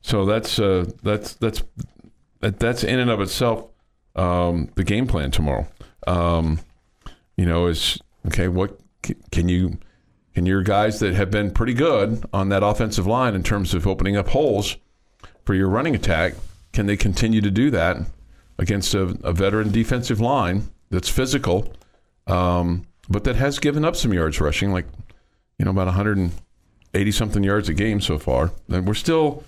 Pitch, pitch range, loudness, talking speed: 100 Hz, 90-110 Hz, -21 LUFS, 175 wpm